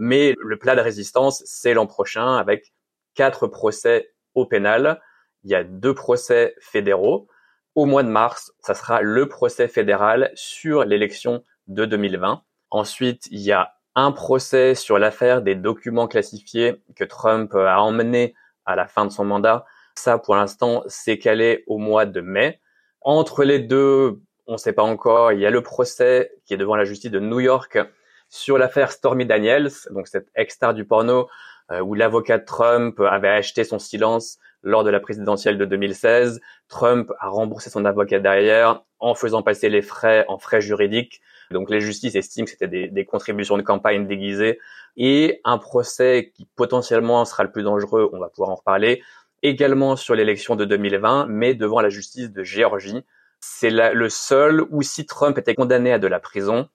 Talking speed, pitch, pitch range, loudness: 180 wpm, 120 Hz, 105-140 Hz, -19 LUFS